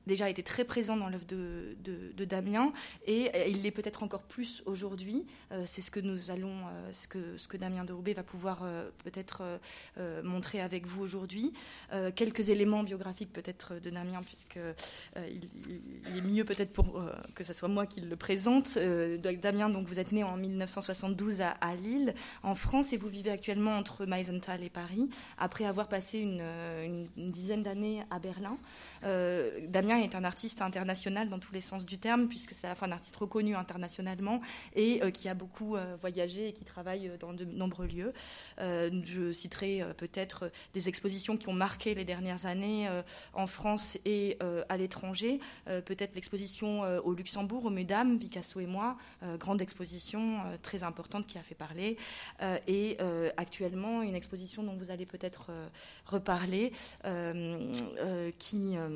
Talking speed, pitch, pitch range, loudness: 190 wpm, 190 Hz, 180-210 Hz, -36 LUFS